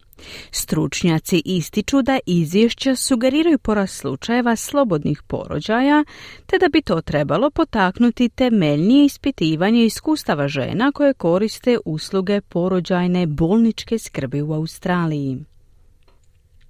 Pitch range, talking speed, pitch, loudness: 155-250 Hz, 95 wpm, 190 Hz, -19 LUFS